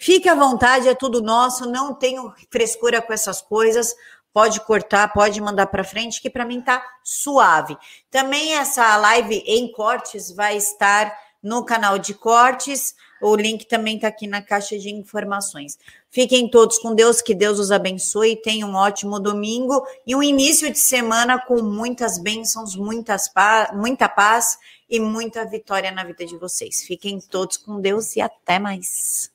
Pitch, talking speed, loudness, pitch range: 220 Hz, 165 wpm, -18 LUFS, 205-245 Hz